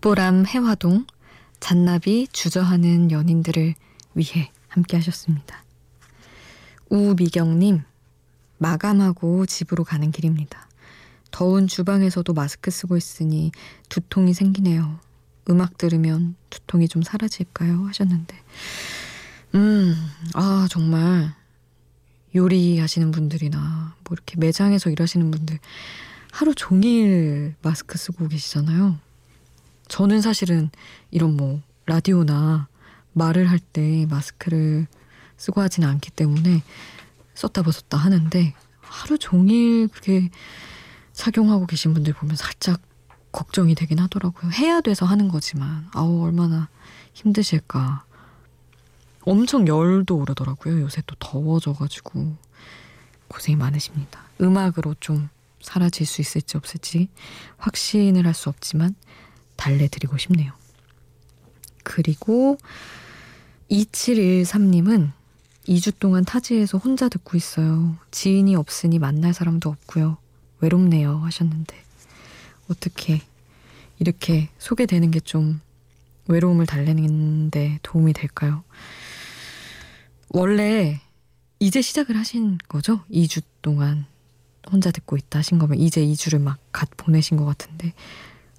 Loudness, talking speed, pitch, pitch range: -21 LUFS, 250 characters per minute, 165 Hz, 150-185 Hz